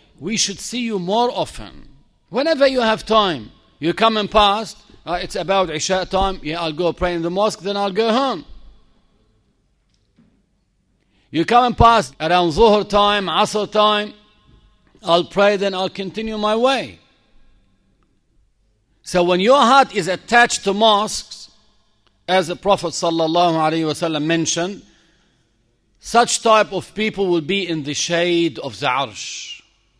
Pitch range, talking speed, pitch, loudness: 170-215 Hz, 145 wpm, 195 Hz, -17 LUFS